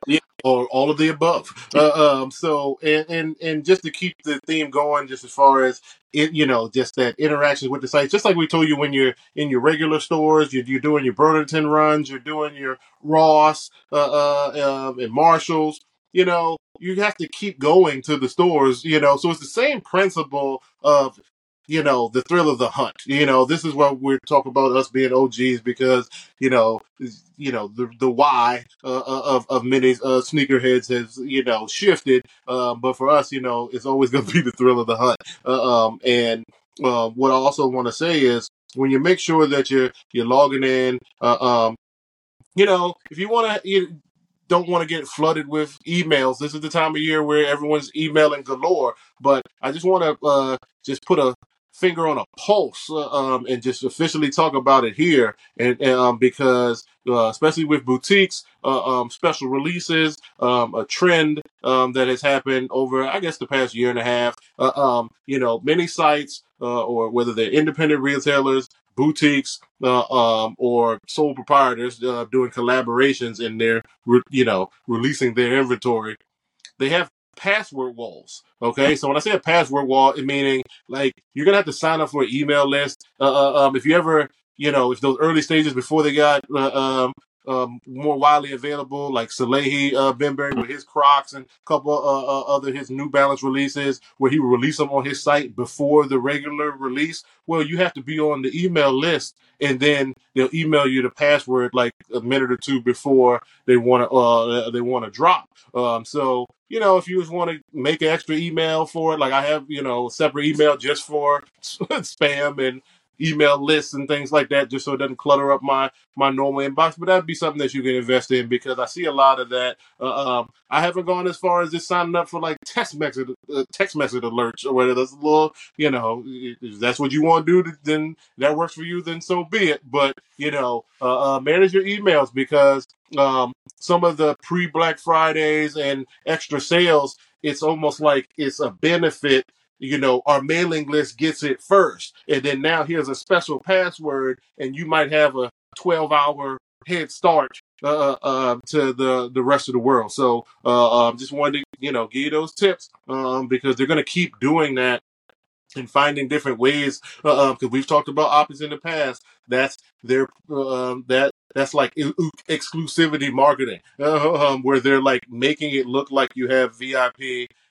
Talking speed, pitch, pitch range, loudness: 205 wpm, 140 Hz, 130-155 Hz, -20 LUFS